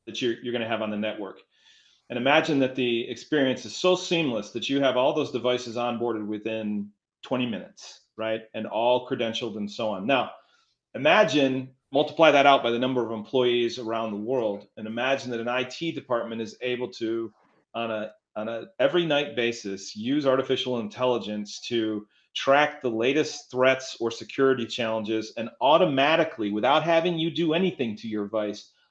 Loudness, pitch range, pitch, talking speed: -26 LUFS, 110-135 Hz, 120 Hz, 175 wpm